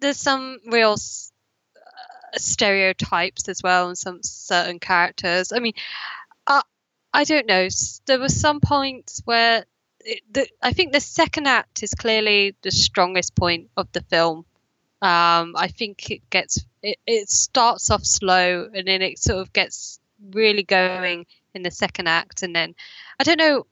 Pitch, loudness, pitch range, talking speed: 200 Hz, -20 LUFS, 180-260 Hz, 160 wpm